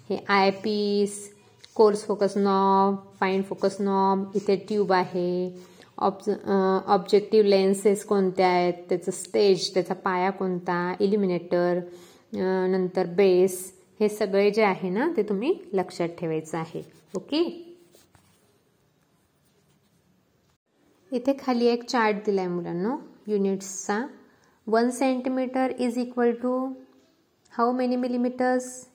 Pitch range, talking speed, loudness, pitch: 185-235 Hz, 110 wpm, -25 LUFS, 200 Hz